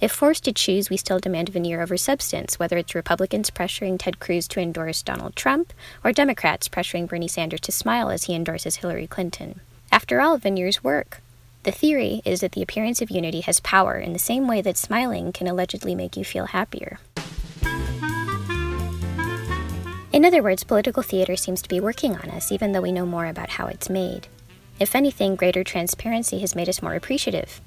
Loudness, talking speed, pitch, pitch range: -23 LUFS, 190 wpm, 185 Hz, 170-215 Hz